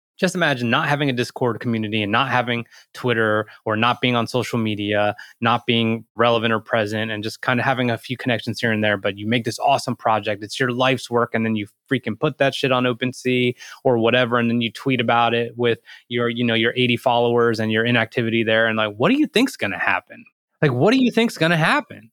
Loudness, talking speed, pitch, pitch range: -20 LUFS, 235 wpm, 120 Hz, 110-125 Hz